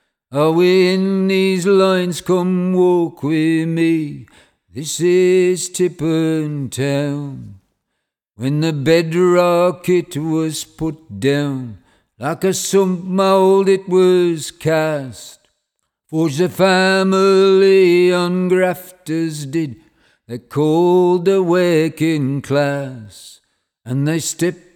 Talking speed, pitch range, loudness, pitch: 100 wpm, 150-185 Hz, -16 LUFS, 165 Hz